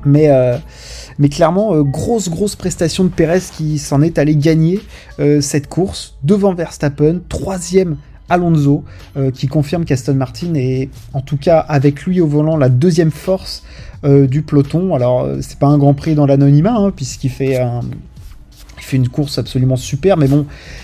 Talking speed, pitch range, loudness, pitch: 175 wpm, 135-170 Hz, -14 LUFS, 150 Hz